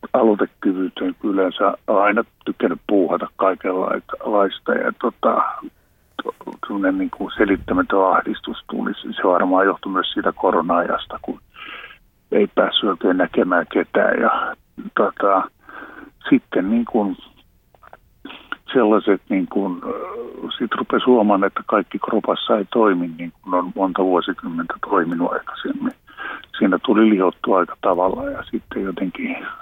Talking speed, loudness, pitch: 110 wpm, -19 LUFS, 260 Hz